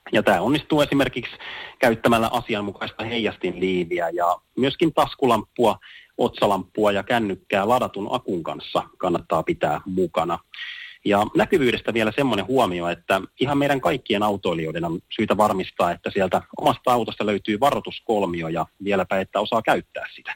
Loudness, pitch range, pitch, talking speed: -22 LUFS, 100-130 Hz, 110 Hz, 130 wpm